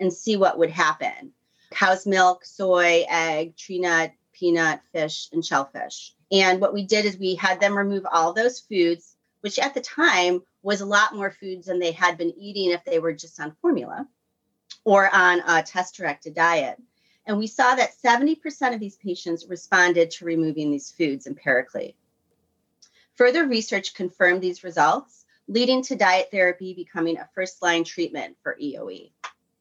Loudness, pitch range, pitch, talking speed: -22 LUFS, 170-215 Hz, 185 Hz, 170 wpm